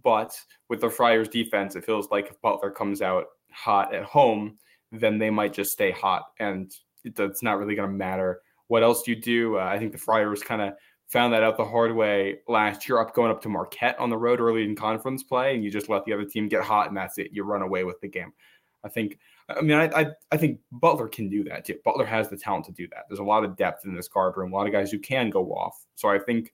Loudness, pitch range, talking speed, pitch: -25 LUFS, 100-115 Hz, 265 wpm, 105 Hz